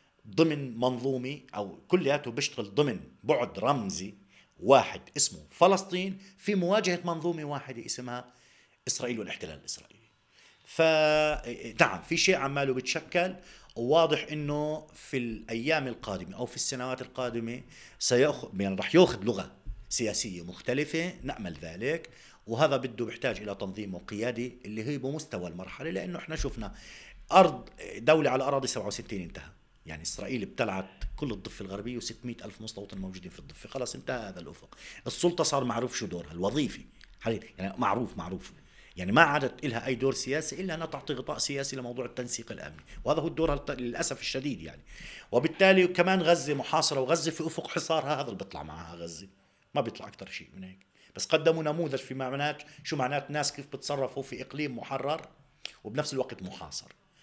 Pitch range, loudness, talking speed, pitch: 115-155 Hz, -30 LUFS, 150 wpm, 135 Hz